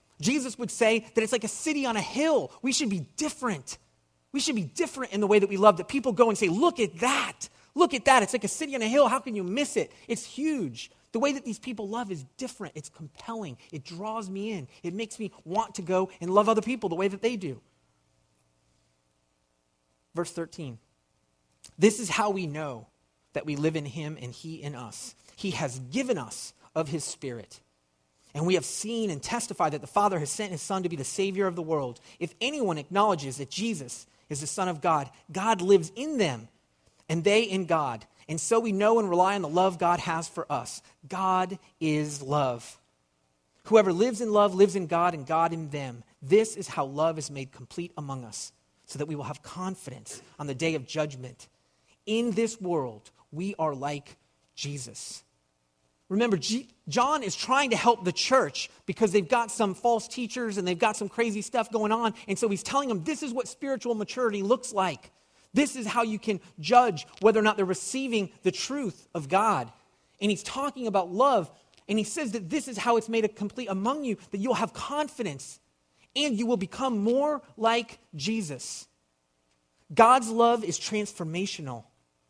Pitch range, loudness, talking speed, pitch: 145-225 Hz, -28 LUFS, 200 wpm, 190 Hz